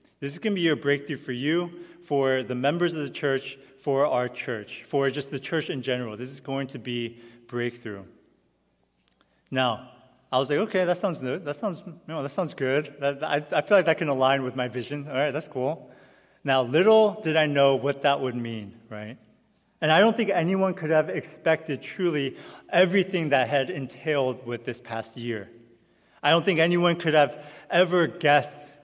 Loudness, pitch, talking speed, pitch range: -25 LUFS, 140 Hz, 195 wpm, 130-165 Hz